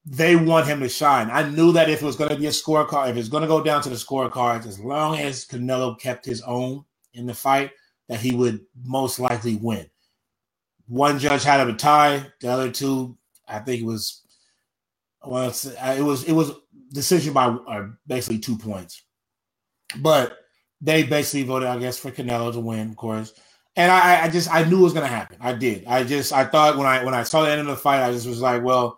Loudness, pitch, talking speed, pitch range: -21 LUFS, 130 Hz, 225 wpm, 120-145 Hz